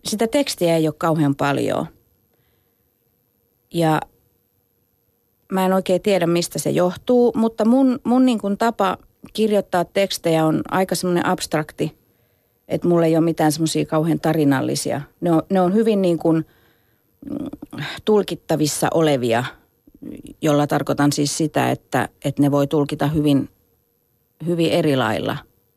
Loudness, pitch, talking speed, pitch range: -19 LUFS, 160 Hz, 130 wpm, 145-190 Hz